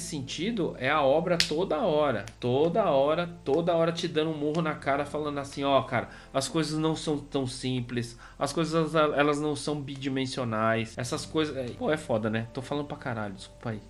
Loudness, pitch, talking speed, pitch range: -28 LUFS, 140 Hz, 195 wpm, 125-155 Hz